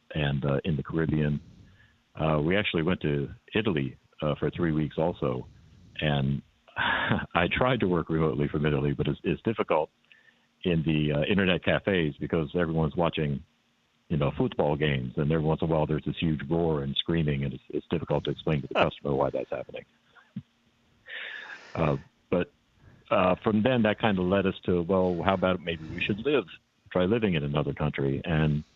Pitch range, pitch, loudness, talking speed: 75-90 Hz, 80 Hz, -28 LUFS, 185 wpm